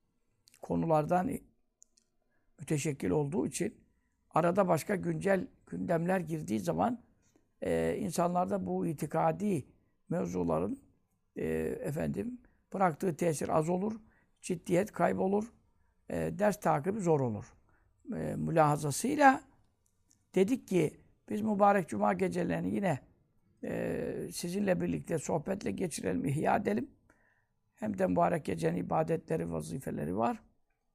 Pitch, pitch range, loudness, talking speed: 170 Hz, 140-195 Hz, -32 LUFS, 100 wpm